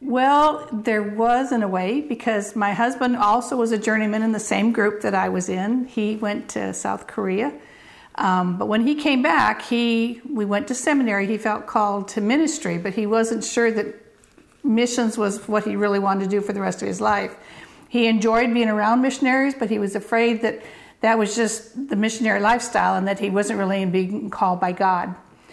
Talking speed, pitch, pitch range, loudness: 200 wpm, 220 Hz, 205-240 Hz, -21 LUFS